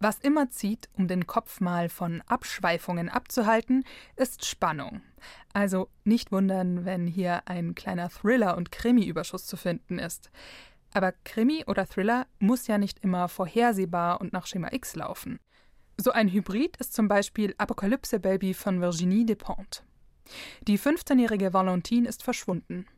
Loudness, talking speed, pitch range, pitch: -28 LUFS, 140 wpm, 180-235 Hz, 200 Hz